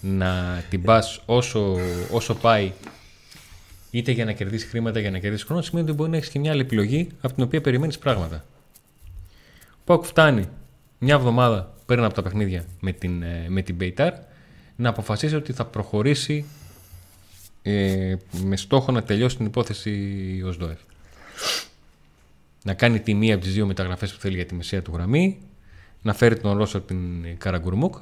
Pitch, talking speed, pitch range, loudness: 100 Hz, 165 wpm, 90-120 Hz, -23 LUFS